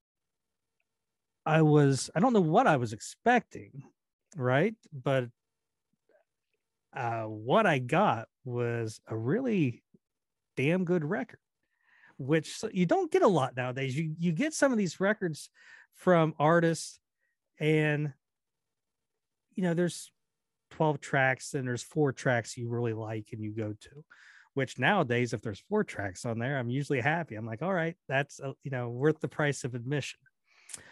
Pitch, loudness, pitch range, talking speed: 145 Hz, -30 LUFS, 125-170 Hz, 150 wpm